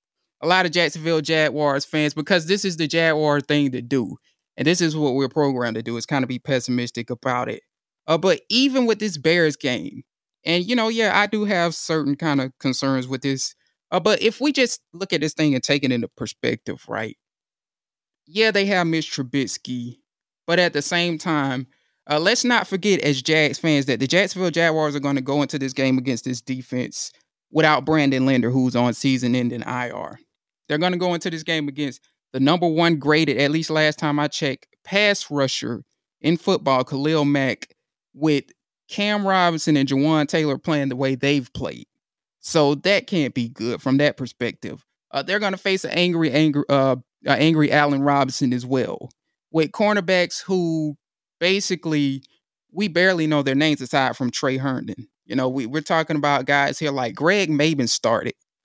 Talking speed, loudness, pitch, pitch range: 190 wpm, -21 LUFS, 150 Hz, 135-170 Hz